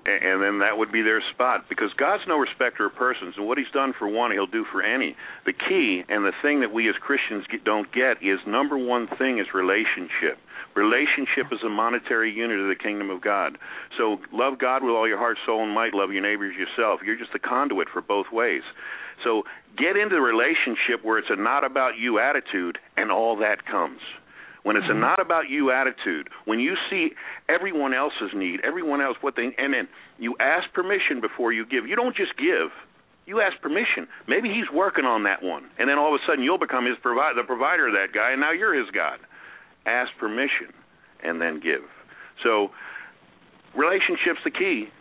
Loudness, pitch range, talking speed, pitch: -24 LUFS, 100-165 Hz, 205 wpm, 115 Hz